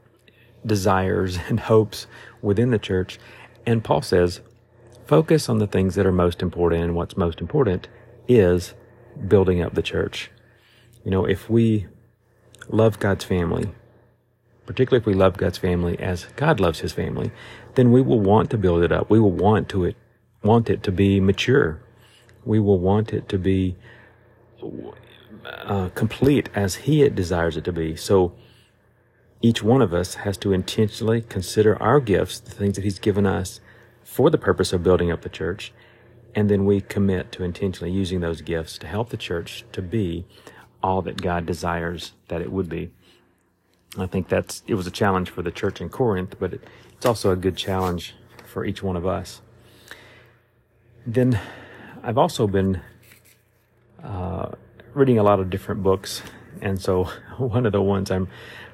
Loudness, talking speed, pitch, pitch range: -22 LUFS, 170 wpm, 105 Hz, 95-120 Hz